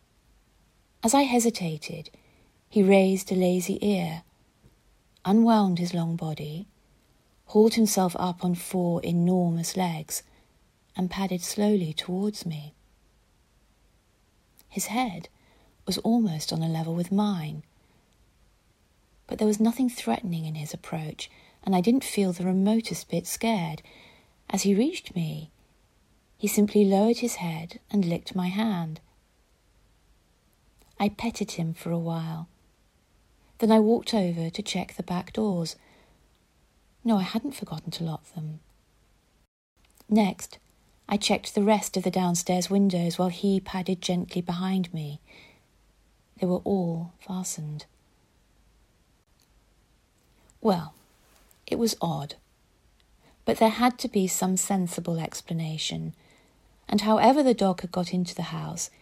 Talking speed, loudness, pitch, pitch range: 125 wpm, -26 LUFS, 180 Hz, 165-210 Hz